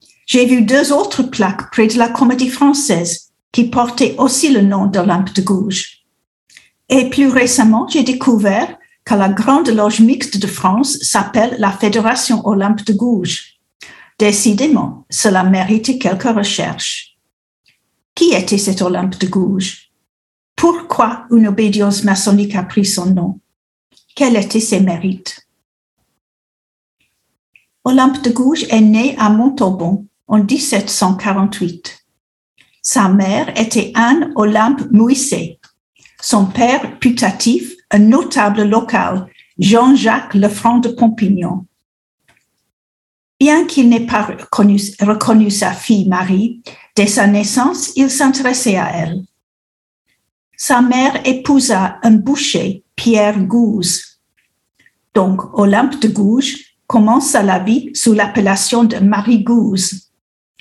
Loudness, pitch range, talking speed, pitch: -13 LUFS, 195-255 Hz, 115 wpm, 220 Hz